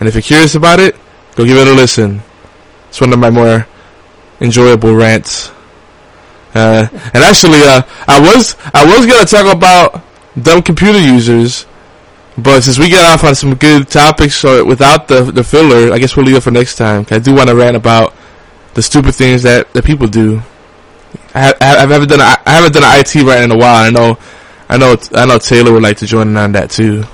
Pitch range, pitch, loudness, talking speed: 110-145 Hz, 120 Hz, -6 LUFS, 210 wpm